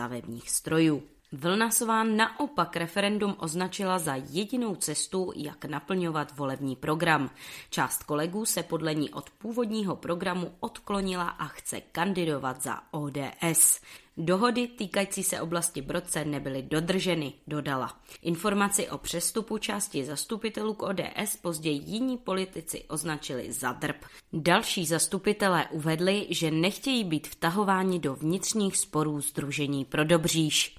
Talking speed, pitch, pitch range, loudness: 120 wpm, 170 Hz, 150-195 Hz, -29 LUFS